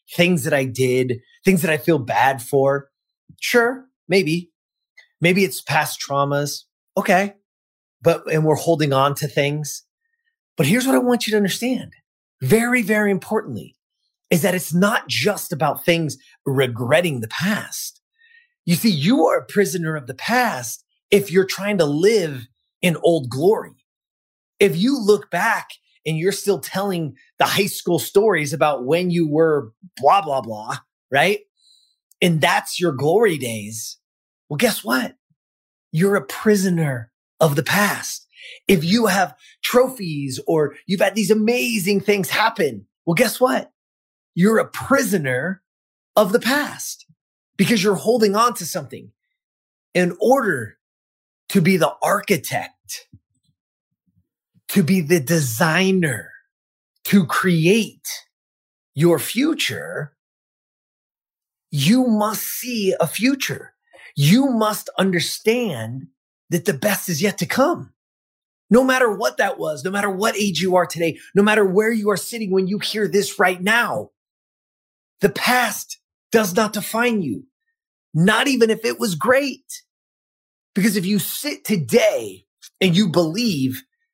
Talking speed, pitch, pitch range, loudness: 140 wpm, 195 Hz, 160-225 Hz, -19 LUFS